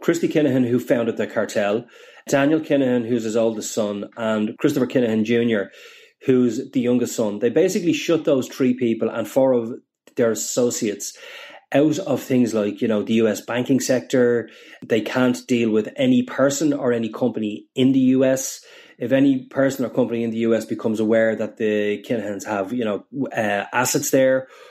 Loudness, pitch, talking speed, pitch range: -21 LUFS, 125 Hz, 175 wpm, 115-135 Hz